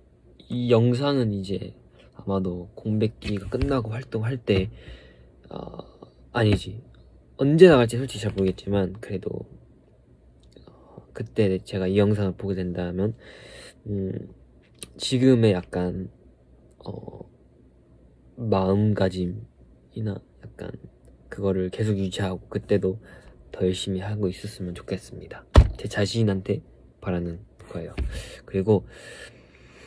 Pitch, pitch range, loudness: 95 Hz, 90-110 Hz, -25 LUFS